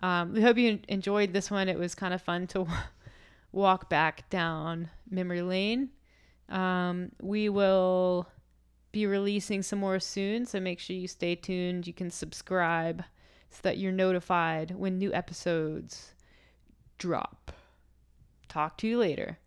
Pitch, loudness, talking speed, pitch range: 185 Hz, -30 LUFS, 150 wpm, 170-195 Hz